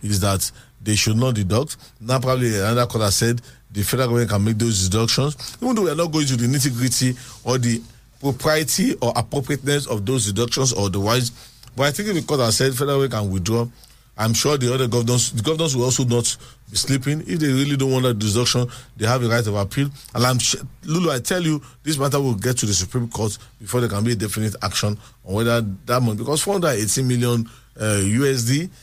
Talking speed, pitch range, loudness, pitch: 225 wpm, 115-135 Hz, -20 LUFS, 125 Hz